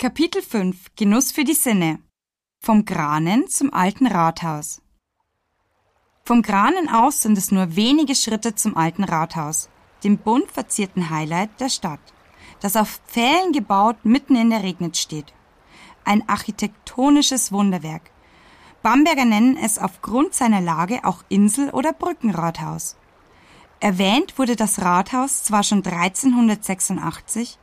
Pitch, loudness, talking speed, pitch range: 215 Hz, -19 LUFS, 125 wpm, 185-255 Hz